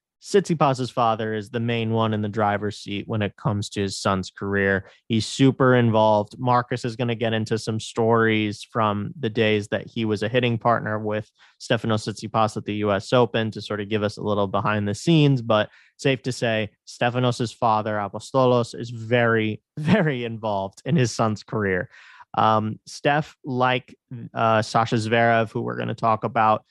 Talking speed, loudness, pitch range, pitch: 180 wpm, -23 LUFS, 105-125 Hz, 110 Hz